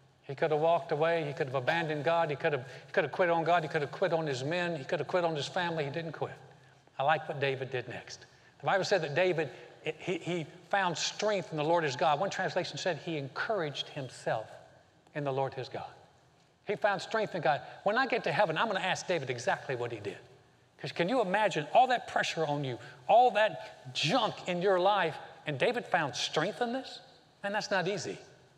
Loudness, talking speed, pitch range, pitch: -31 LUFS, 235 wpm, 145-185 Hz, 165 Hz